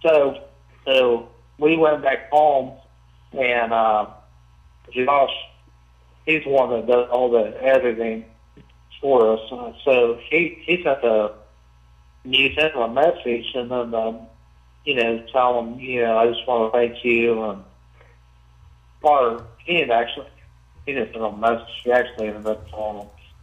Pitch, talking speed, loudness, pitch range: 115 Hz, 150 wpm, -20 LUFS, 80-130 Hz